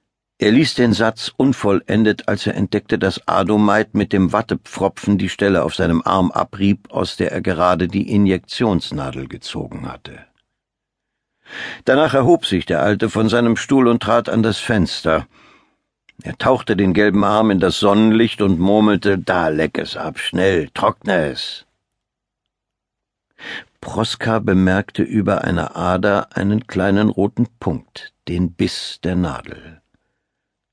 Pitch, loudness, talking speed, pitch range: 105 Hz, -17 LUFS, 135 wpm, 95-110 Hz